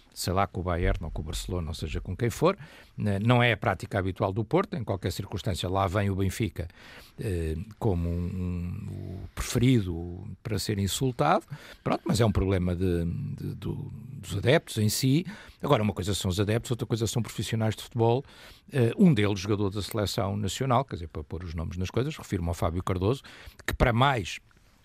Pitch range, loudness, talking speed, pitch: 95-115 Hz, -28 LUFS, 195 wpm, 105 Hz